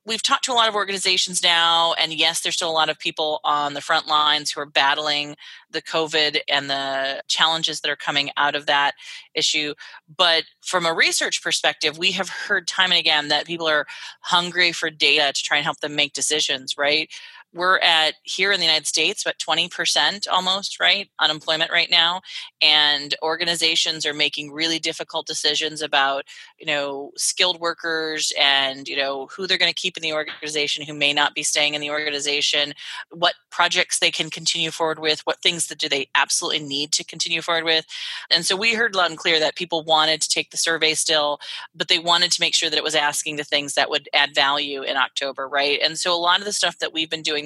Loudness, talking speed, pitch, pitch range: -19 LUFS, 210 wpm, 160 Hz, 150-170 Hz